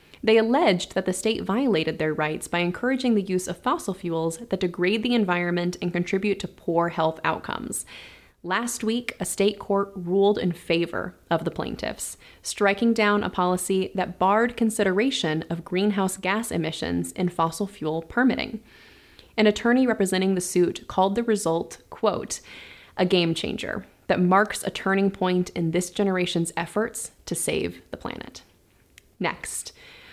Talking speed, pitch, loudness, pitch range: 150 wpm, 190 Hz, -25 LUFS, 175-215 Hz